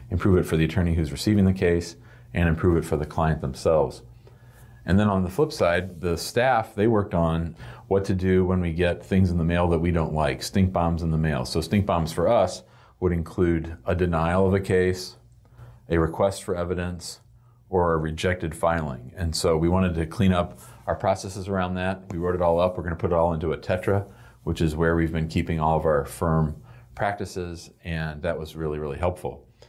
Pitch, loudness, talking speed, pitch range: 90 Hz, -24 LUFS, 220 wpm, 80-100 Hz